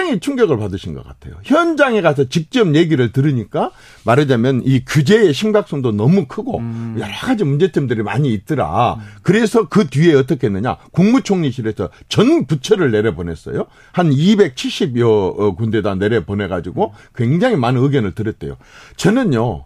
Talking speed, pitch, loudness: 345 characters per minute, 135 Hz, -16 LUFS